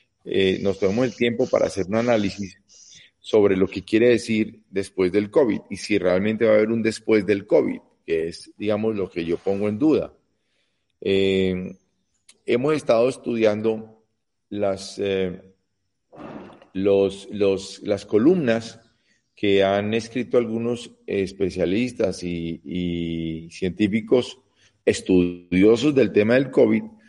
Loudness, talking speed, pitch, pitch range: -22 LUFS, 130 wpm, 105 Hz, 95-115 Hz